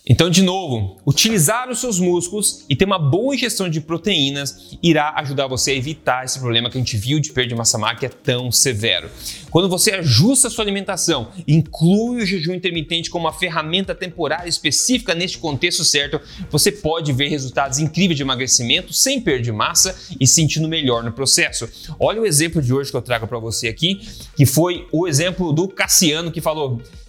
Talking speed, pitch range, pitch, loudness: 190 wpm, 130-180 Hz, 155 Hz, -17 LUFS